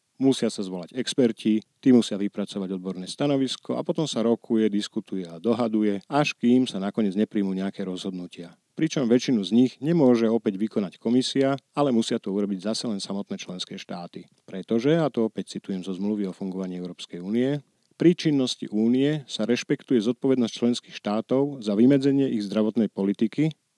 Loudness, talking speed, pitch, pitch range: -25 LUFS, 160 wpm, 115 Hz, 100-130 Hz